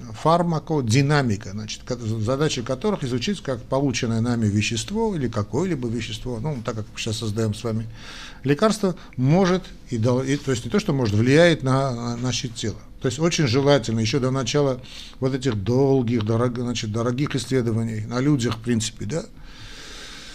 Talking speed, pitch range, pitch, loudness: 155 wpm, 115-145 Hz, 125 Hz, -23 LUFS